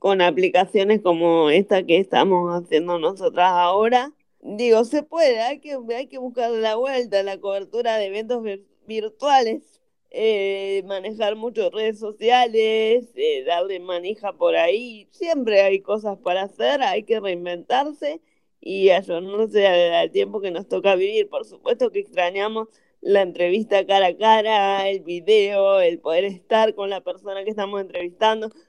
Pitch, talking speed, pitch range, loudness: 205 Hz, 150 wpm, 190-235 Hz, -21 LUFS